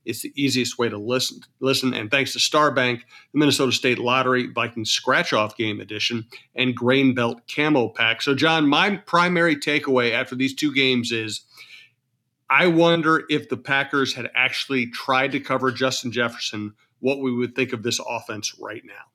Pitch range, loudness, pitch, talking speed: 120-140 Hz, -21 LUFS, 130 Hz, 175 wpm